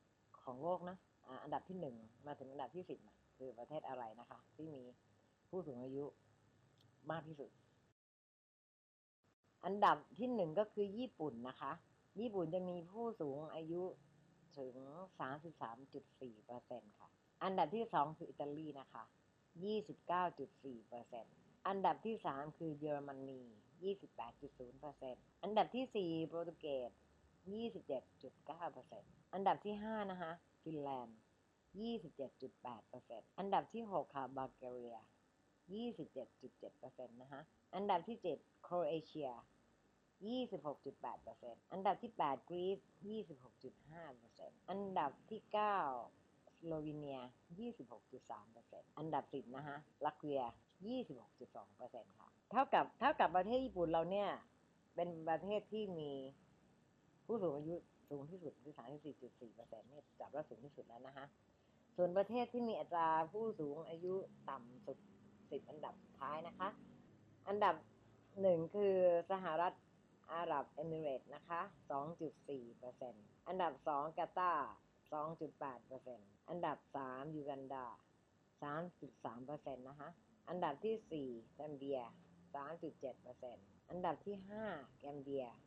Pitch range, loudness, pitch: 130-180 Hz, -45 LUFS, 150 Hz